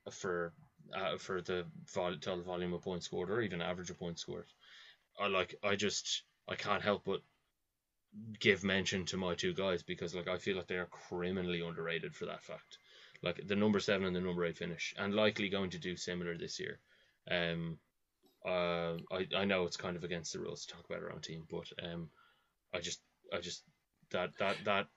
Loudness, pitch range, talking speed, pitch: -38 LUFS, 85-95 Hz, 200 wpm, 90 Hz